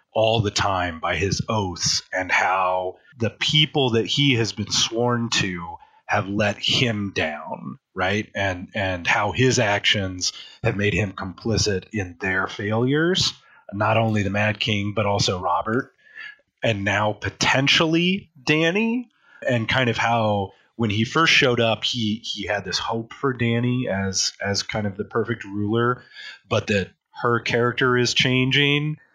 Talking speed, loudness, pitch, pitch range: 150 wpm, -21 LUFS, 115 Hz, 105-130 Hz